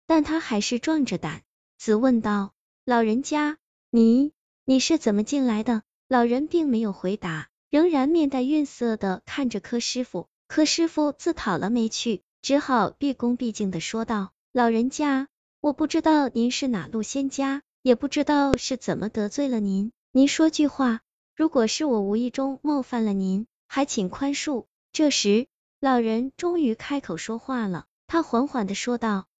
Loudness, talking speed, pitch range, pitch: -24 LUFS, 240 characters per minute, 220-285 Hz, 250 Hz